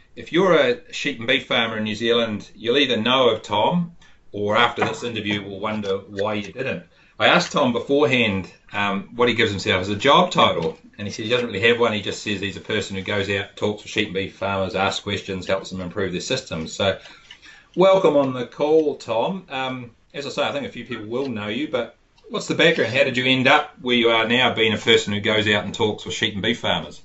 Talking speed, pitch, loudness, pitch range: 245 wpm, 110 Hz, -21 LUFS, 100-125 Hz